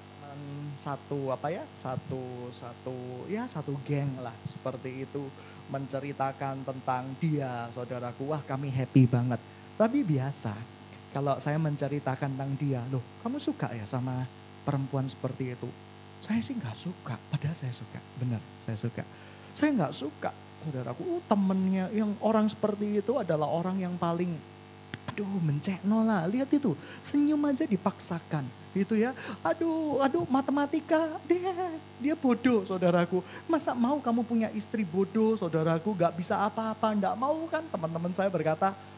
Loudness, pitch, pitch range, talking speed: -31 LUFS, 155 Hz, 130-215 Hz, 140 wpm